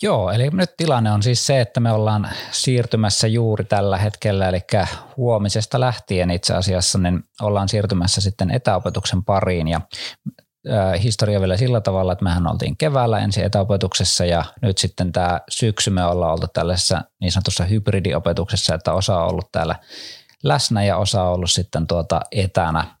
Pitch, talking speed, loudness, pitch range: 100 Hz, 160 wpm, -19 LUFS, 90-110 Hz